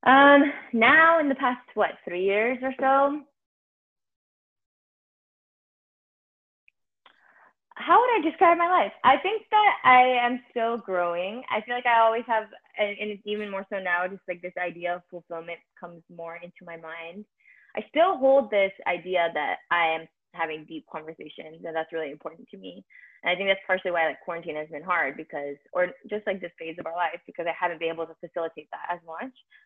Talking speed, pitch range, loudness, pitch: 190 wpm, 170-245 Hz, -24 LUFS, 185 Hz